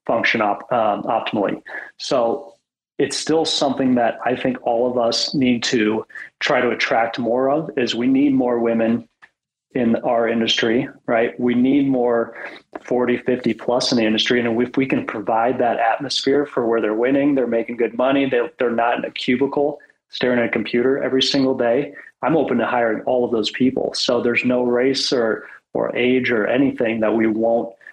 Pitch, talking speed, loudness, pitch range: 125 Hz, 190 wpm, -19 LUFS, 115-130 Hz